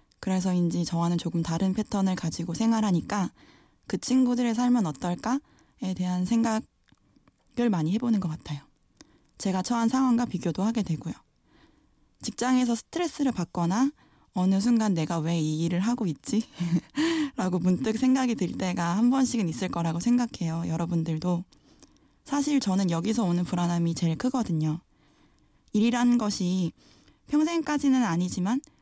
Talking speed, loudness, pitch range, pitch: 315 characters per minute, -27 LUFS, 170-240 Hz, 190 Hz